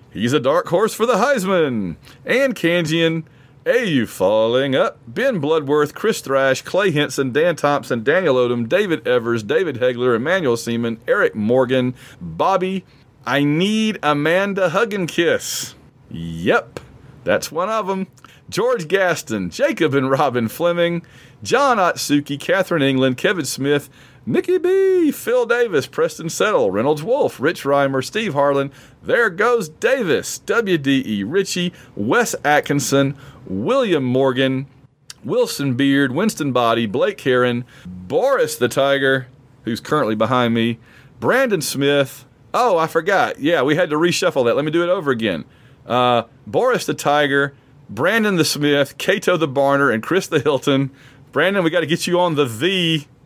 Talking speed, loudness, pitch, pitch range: 145 wpm, -18 LUFS, 140 Hz, 130-180 Hz